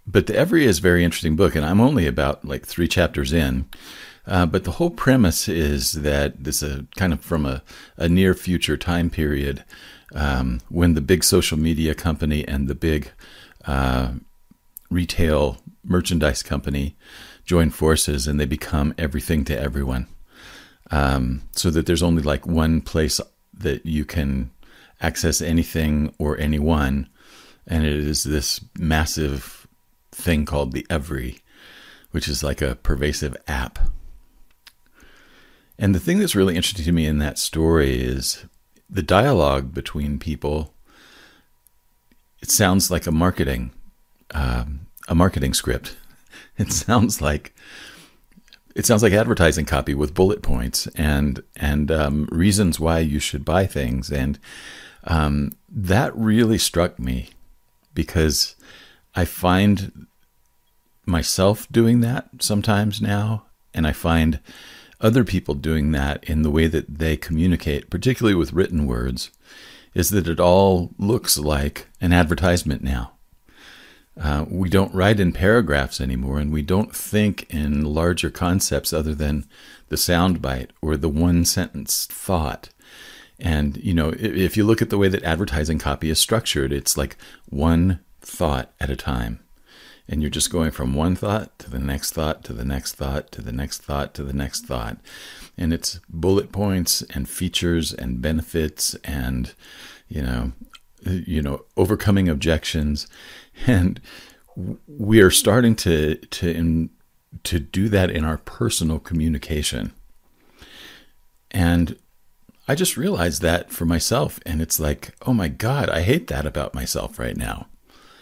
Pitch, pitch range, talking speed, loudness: 80 Hz, 70-90 Hz, 150 wpm, -21 LUFS